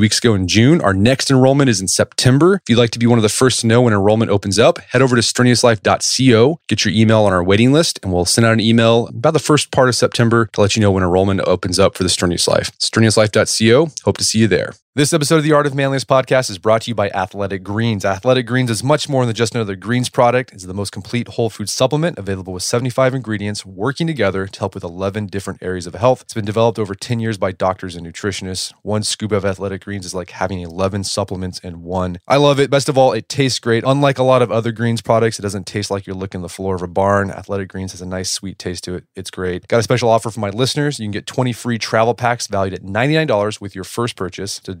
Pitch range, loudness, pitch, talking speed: 95-125 Hz, -16 LUFS, 110 Hz, 260 wpm